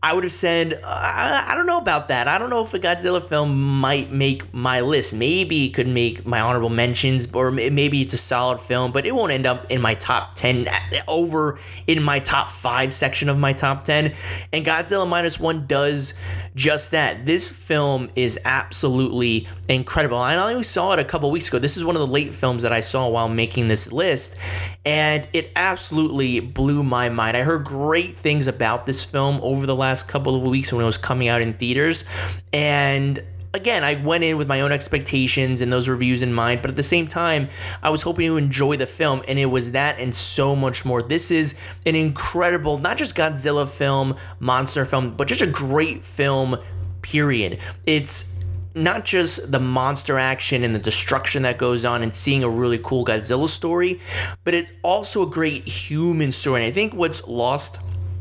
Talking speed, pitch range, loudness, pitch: 200 wpm, 120-150 Hz, -20 LUFS, 135 Hz